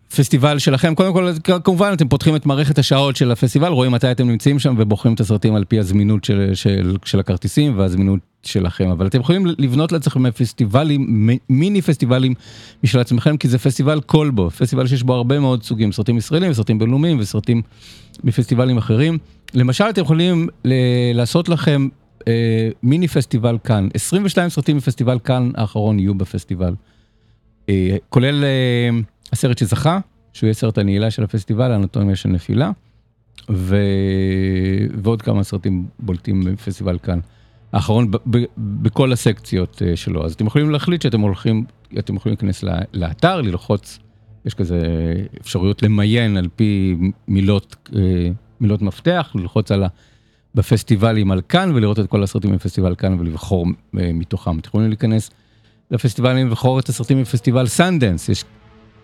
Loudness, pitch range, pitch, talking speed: -17 LUFS, 100-130 Hz, 115 Hz, 145 wpm